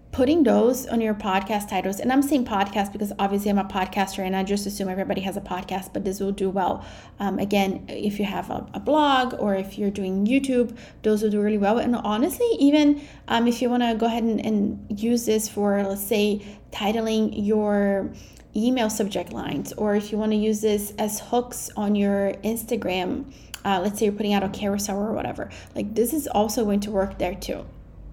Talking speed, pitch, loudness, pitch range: 210 wpm, 210 Hz, -24 LUFS, 200-230 Hz